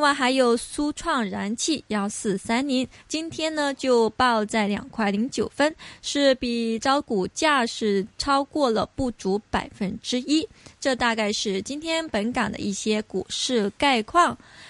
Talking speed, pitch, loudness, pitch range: 215 characters per minute, 245 Hz, -24 LUFS, 215-280 Hz